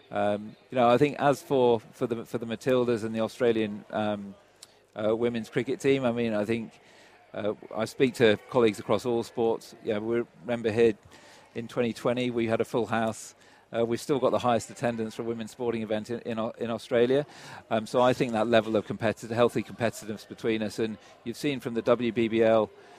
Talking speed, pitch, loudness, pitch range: 200 wpm, 115 Hz, -28 LUFS, 110-120 Hz